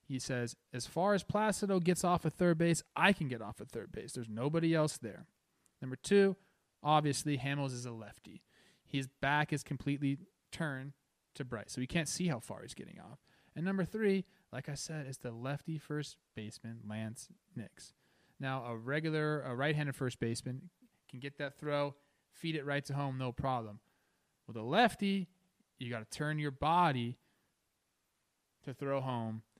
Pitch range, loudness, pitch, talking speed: 125-165 Hz, -36 LUFS, 140 Hz, 180 wpm